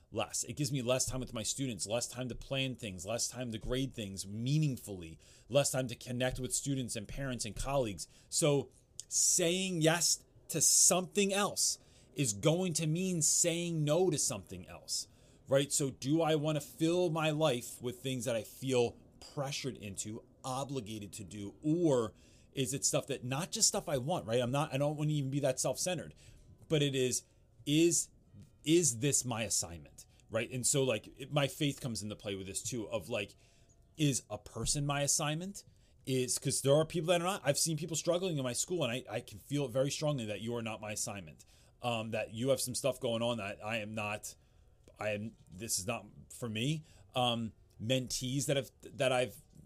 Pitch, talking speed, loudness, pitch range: 130 Hz, 205 wpm, -34 LUFS, 115-150 Hz